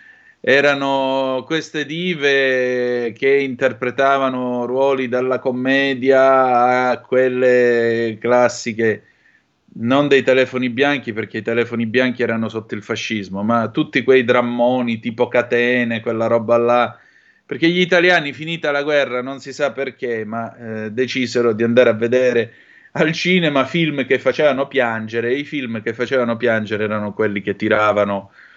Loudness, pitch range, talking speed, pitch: -17 LUFS, 115-135 Hz, 135 wpm, 125 Hz